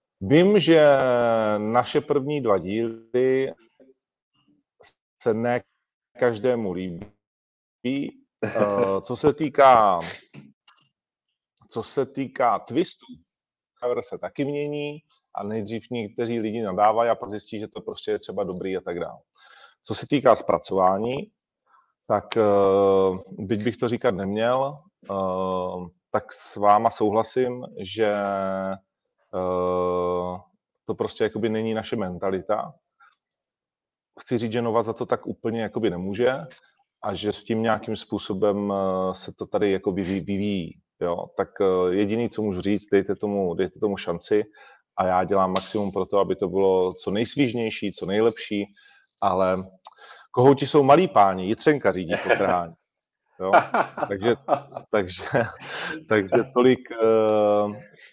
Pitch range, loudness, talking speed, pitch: 95-125 Hz, -24 LUFS, 120 wpm, 110 Hz